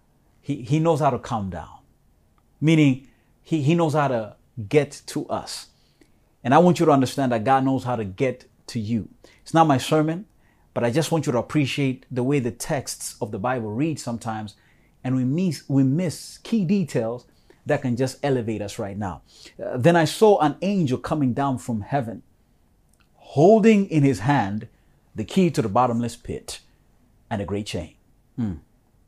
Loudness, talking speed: -22 LUFS, 185 wpm